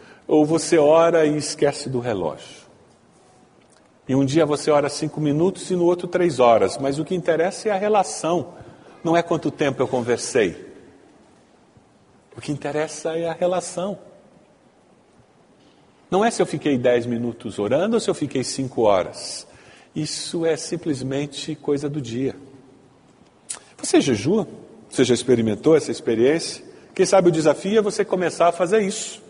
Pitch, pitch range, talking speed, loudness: 155 Hz, 135-180 Hz, 155 wpm, -21 LUFS